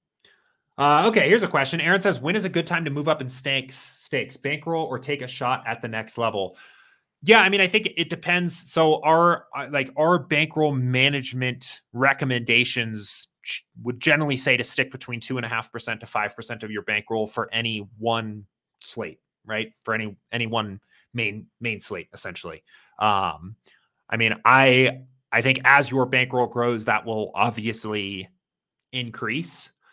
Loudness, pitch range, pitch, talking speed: -22 LUFS, 115-145 Hz, 125 Hz, 160 wpm